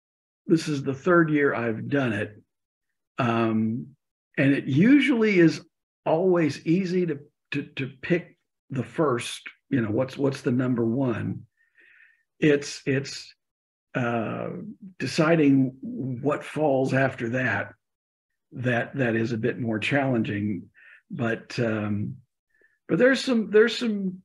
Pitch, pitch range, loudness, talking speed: 140 Hz, 120-175 Hz, -25 LUFS, 125 wpm